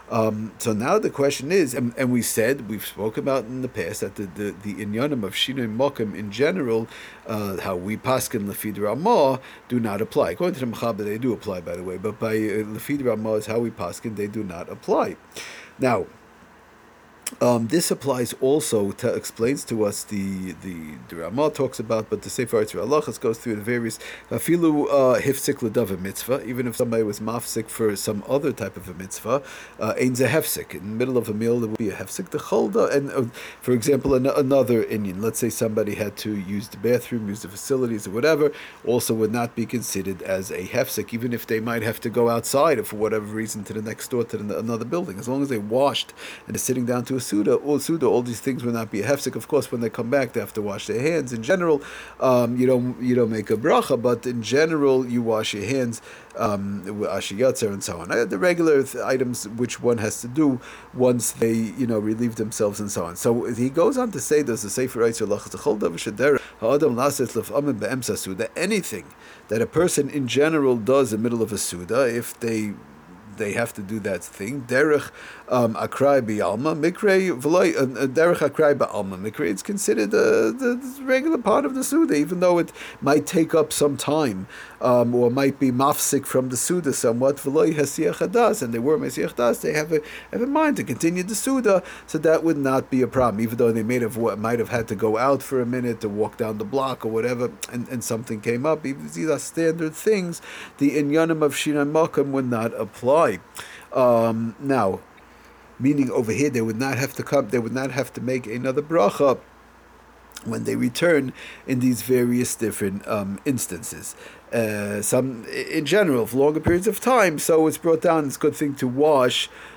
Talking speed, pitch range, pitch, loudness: 200 wpm, 110-140 Hz, 125 Hz, -23 LUFS